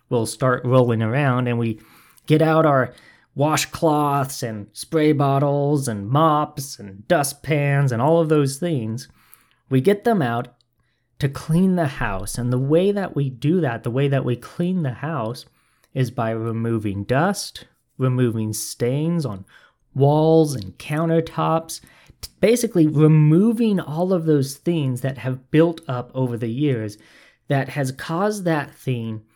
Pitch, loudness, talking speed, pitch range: 140 Hz, -20 LUFS, 150 wpm, 120-160 Hz